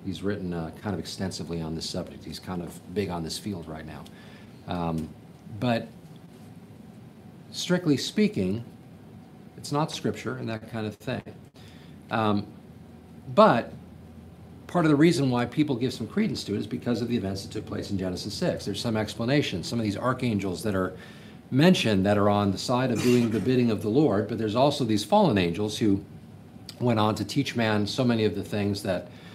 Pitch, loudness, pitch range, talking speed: 105 Hz, -26 LUFS, 95-120 Hz, 190 wpm